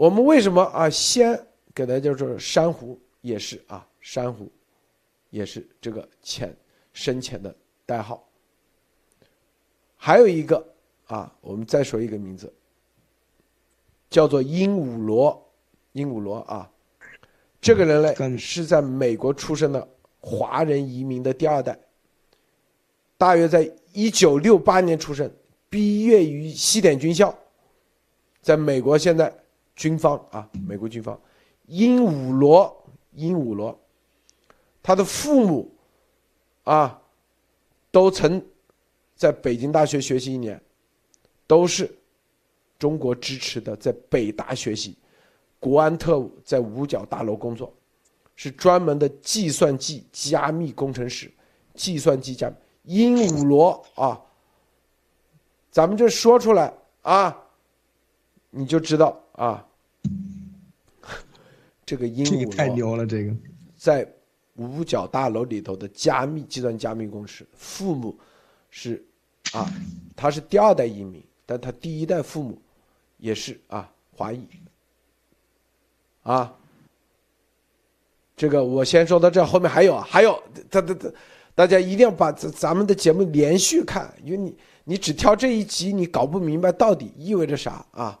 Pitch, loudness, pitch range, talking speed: 150 Hz, -21 LUFS, 125-180 Hz, 190 characters per minute